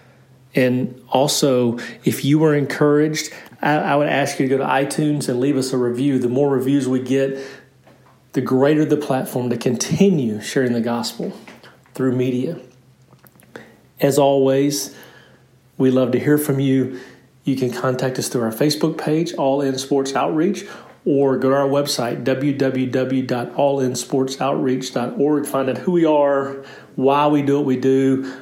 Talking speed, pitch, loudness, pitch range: 155 wpm, 135 Hz, -19 LUFS, 130-140 Hz